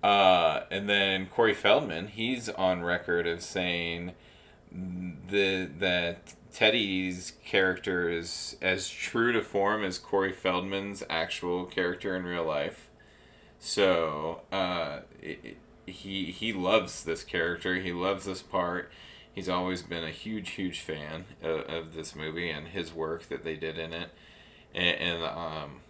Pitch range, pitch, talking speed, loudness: 85-95 Hz, 90 Hz, 145 wpm, -30 LUFS